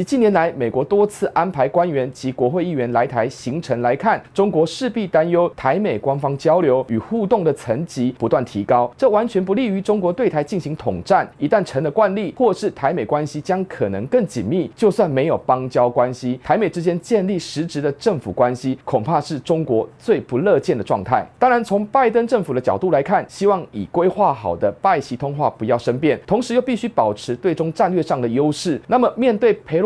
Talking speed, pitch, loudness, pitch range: 310 characters per minute, 160 Hz, -19 LUFS, 130-200 Hz